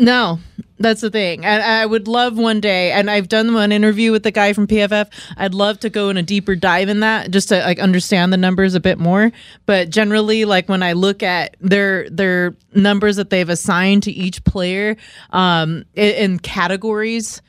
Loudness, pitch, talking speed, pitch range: -15 LUFS, 200 Hz, 200 wpm, 185-215 Hz